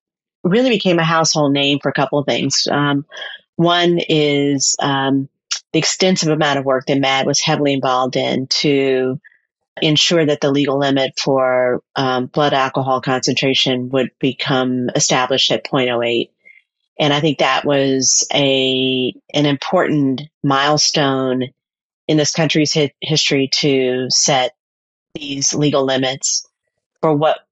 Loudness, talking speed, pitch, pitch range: -16 LUFS, 135 wpm, 140 Hz, 130-150 Hz